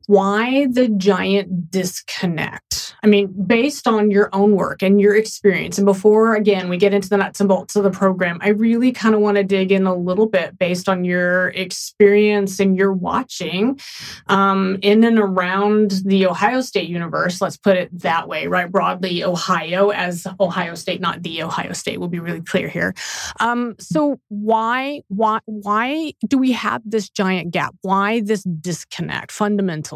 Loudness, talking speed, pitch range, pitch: -18 LUFS, 175 wpm, 185-215 Hz, 195 Hz